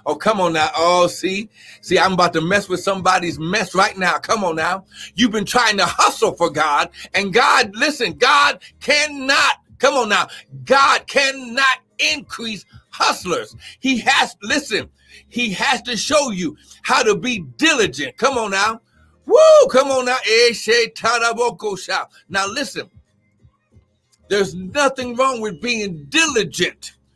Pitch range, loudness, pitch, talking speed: 180-265 Hz, -17 LUFS, 220 Hz, 145 wpm